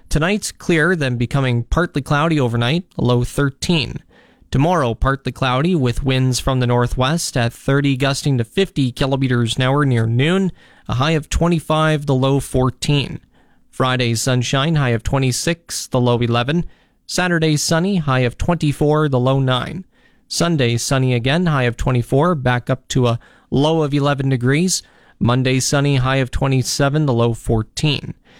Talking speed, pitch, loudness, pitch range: 150 wpm, 135 Hz, -18 LUFS, 125-155 Hz